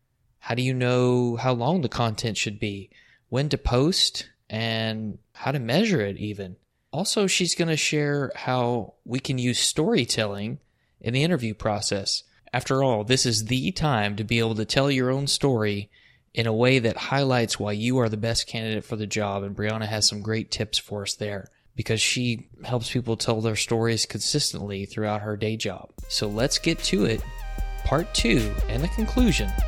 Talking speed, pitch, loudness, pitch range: 185 wpm, 115 Hz, -25 LUFS, 105-130 Hz